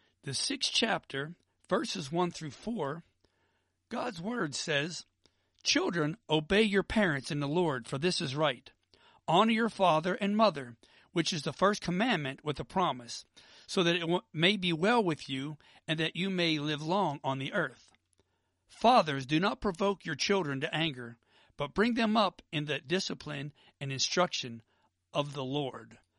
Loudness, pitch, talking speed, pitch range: -31 LUFS, 160 Hz, 165 wpm, 140-185 Hz